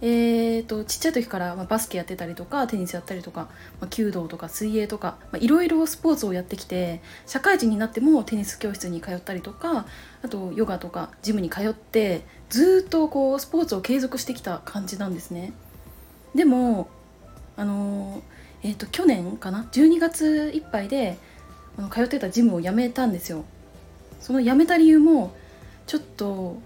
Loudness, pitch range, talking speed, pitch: -23 LUFS, 185-265 Hz, 345 characters per minute, 215 Hz